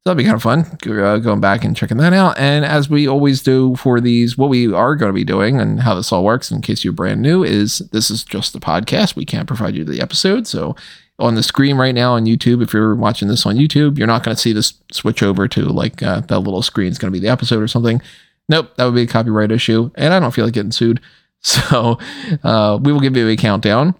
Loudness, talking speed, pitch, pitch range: -15 LUFS, 270 wpm, 120 Hz, 110-145 Hz